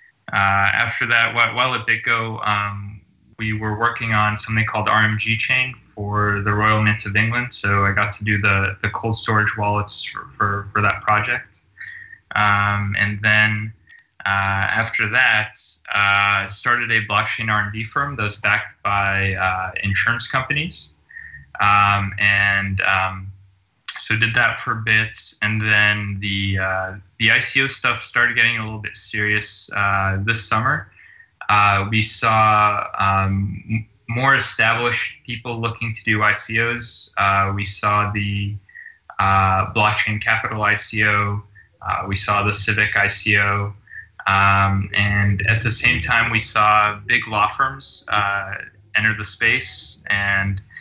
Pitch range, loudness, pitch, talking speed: 100-110 Hz, -18 LUFS, 105 Hz, 145 wpm